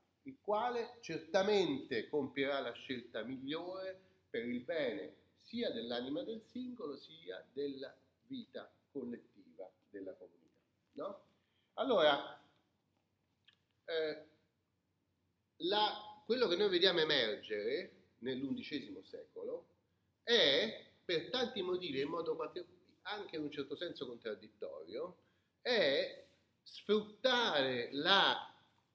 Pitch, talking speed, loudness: 205 Hz, 95 wpm, -37 LUFS